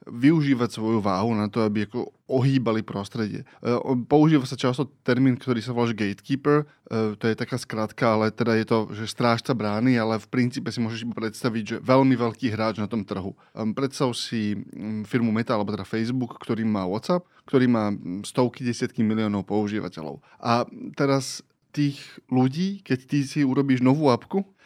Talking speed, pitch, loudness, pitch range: 165 wpm, 120 Hz, -25 LUFS, 110-130 Hz